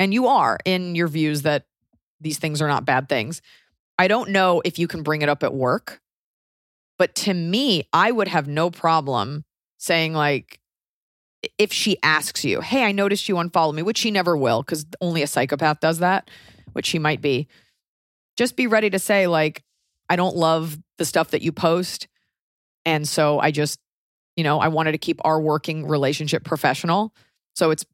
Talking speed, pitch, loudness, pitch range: 190 wpm, 160 Hz, -21 LUFS, 150-180 Hz